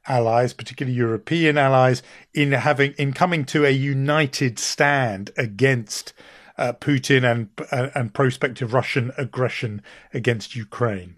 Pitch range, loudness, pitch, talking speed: 120-140 Hz, -21 LUFS, 130 Hz, 120 wpm